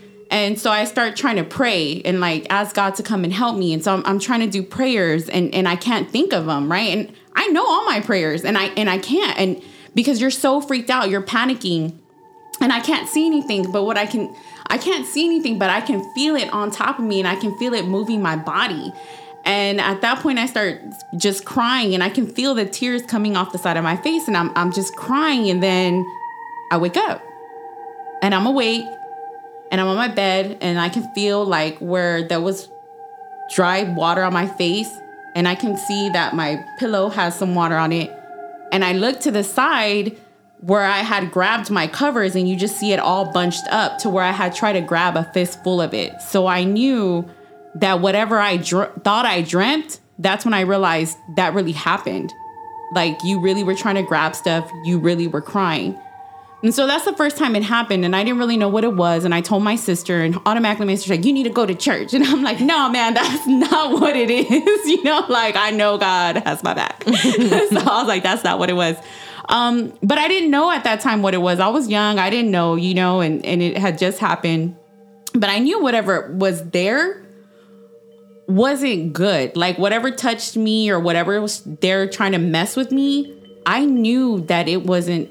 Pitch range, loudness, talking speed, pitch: 180-250 Hz, -18 LUFS, 225 wpm, 205 Hz